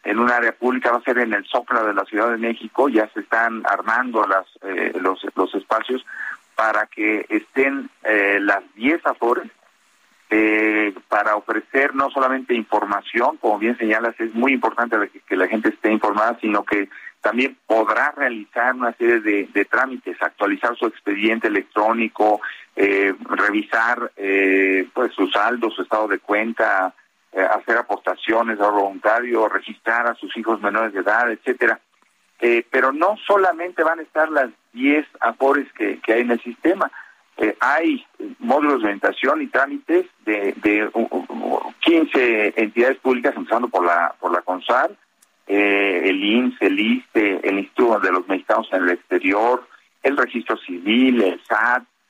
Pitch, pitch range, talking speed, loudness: 115 Hz, 105-135 Hz, 160 wpm, -19 LUFS